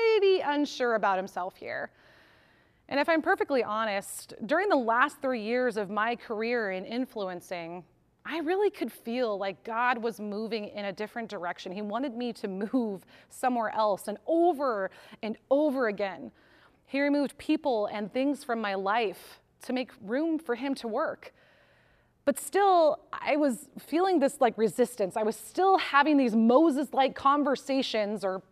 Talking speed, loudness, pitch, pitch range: 160 wpm, -29 LUFS, 245 Hz, 215-285 Hz